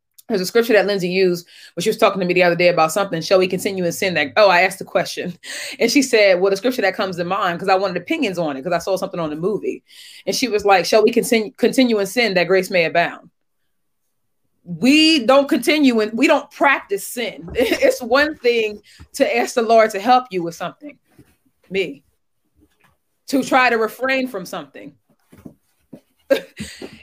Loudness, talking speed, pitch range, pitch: -17 LUFS, 205 wpm, 185-255 Hz, 210 Hz